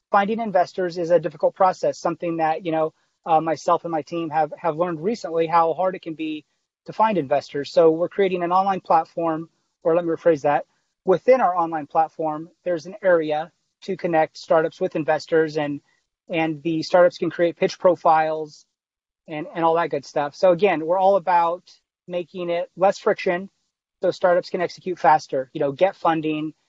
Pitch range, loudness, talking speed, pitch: 160-185 Hz, -22 LUFS, 185 wpm, 170 Hz